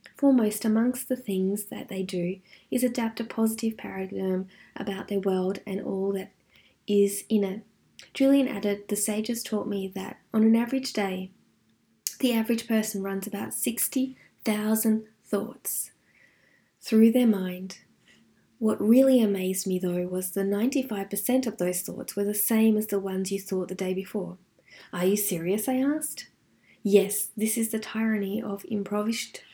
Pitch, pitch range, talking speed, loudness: 205 Hz, 195-225 Hz, 155 wpm, -27 LUFS